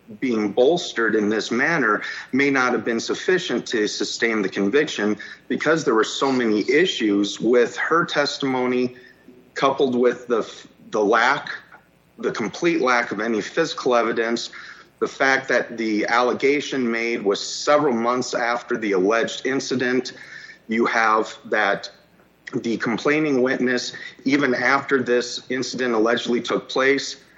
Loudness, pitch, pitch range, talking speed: -21 LUFS, 125 Hz, 115-135 Hz, 135 wpm